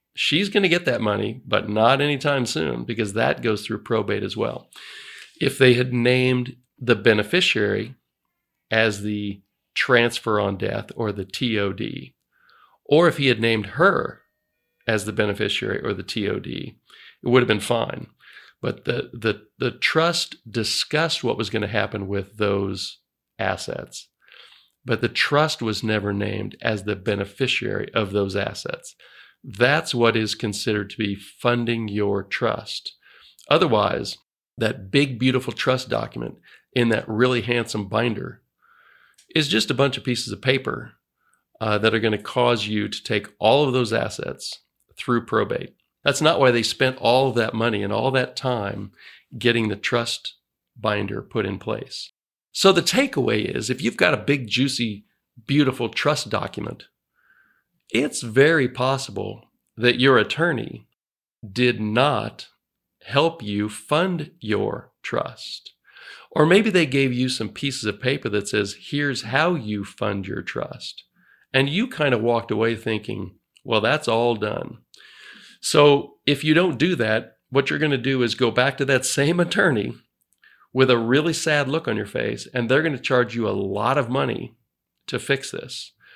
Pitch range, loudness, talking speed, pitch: 105-135 Hz, -22 LUFS, 160 wpm, 120 Hz